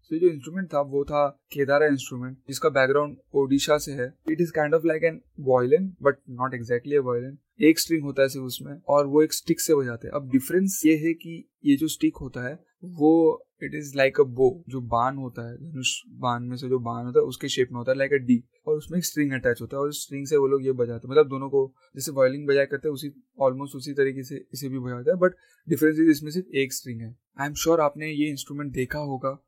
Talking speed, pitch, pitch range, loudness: 240 wpm, 140 Hz, 130-155 Hz, -25 LUFS